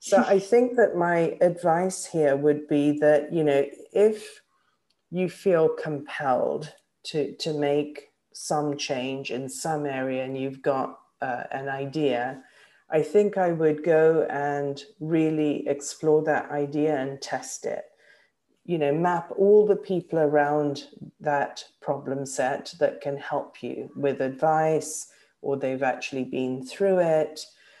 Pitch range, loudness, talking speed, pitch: 140-170 Hz, -25 LUFS, 140 wpm, 150 Hz